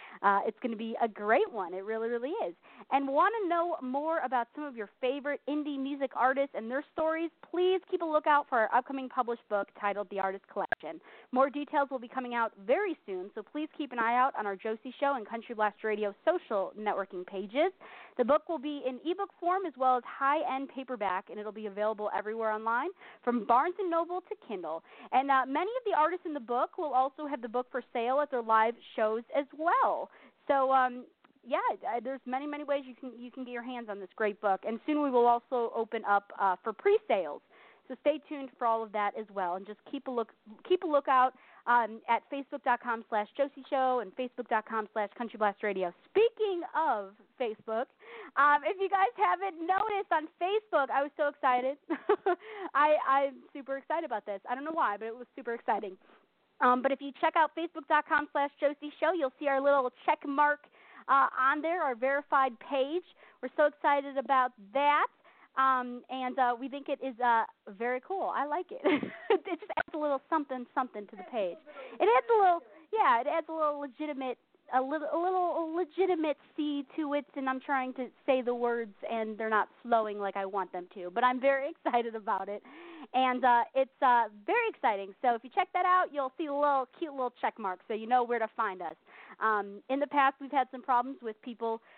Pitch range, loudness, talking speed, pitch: 230-300 Hz, -31 LUFS, 215 wpm, 265 Hz